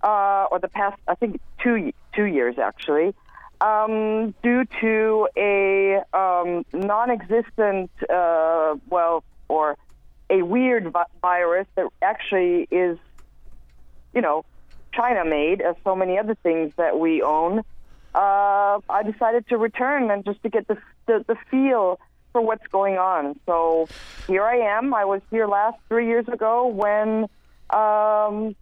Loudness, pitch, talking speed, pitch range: -22 LUFS, 200 Hz, 145 wpm, 175-220 Hz